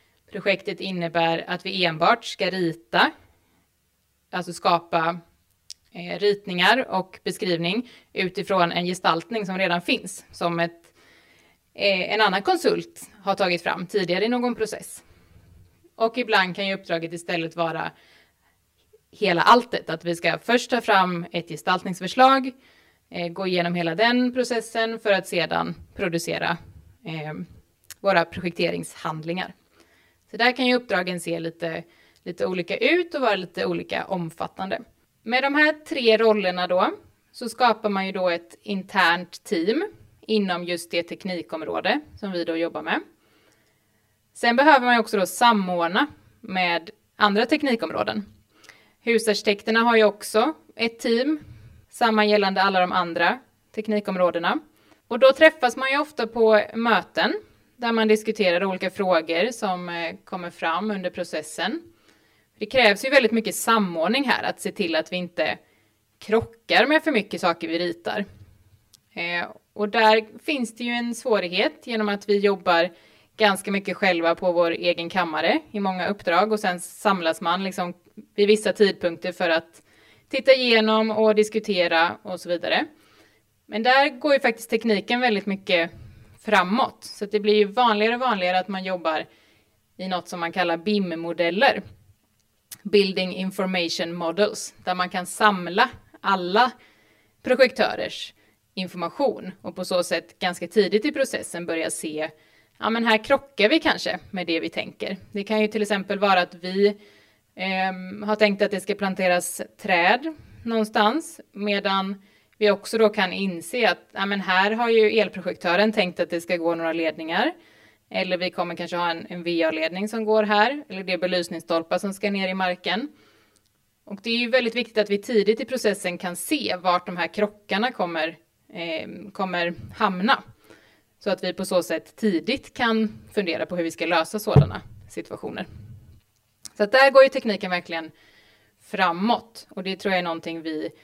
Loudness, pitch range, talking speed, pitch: -23 LUFS, 165-215 Hz, 150 wpm, 185 Hz